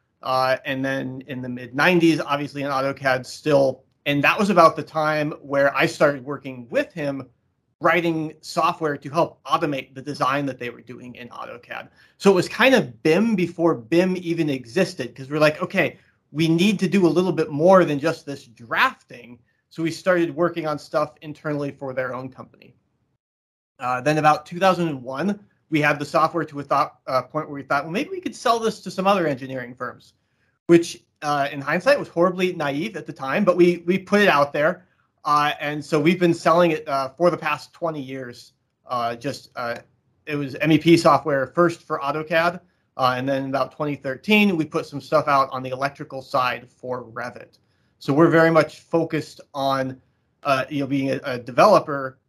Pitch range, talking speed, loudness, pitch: 135-170 Hz, 195 wpm, -21 LUFS, 150 Hz